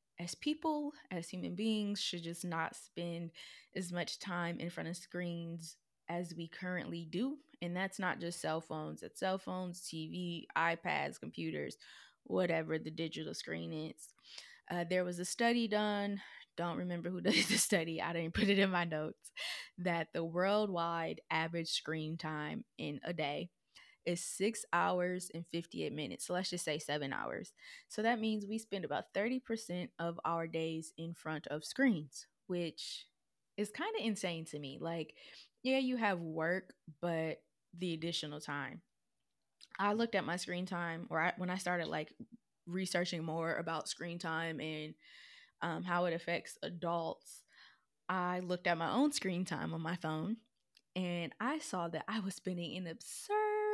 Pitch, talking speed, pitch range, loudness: 175 Hz, 165 wpm, 165-195 Hz, -38 LUFS